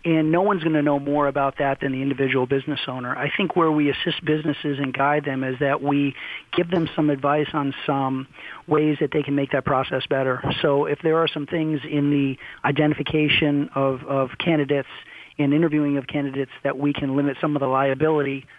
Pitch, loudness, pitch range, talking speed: 145 Hz, -22 LUFS, 140-150 Hz, 205 wpm